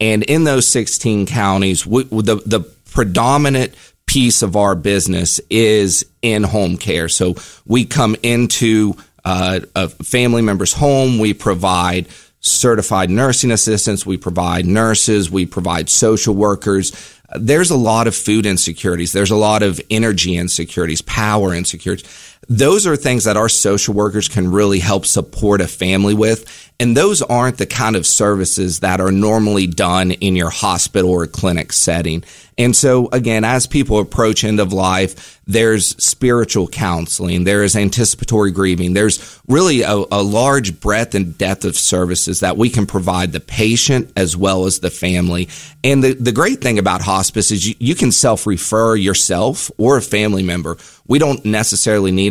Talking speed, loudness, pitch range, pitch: 165 wpm, -14 LUFS, 95-115 Hz, 105 Hz